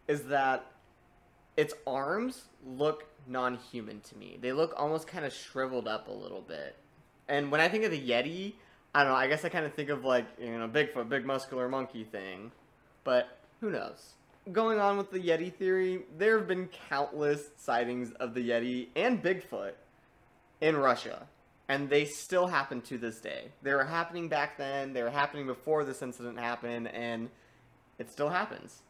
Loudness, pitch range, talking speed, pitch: -32 LUFS, 125-155 Hz, 185 wpm, 140 Hz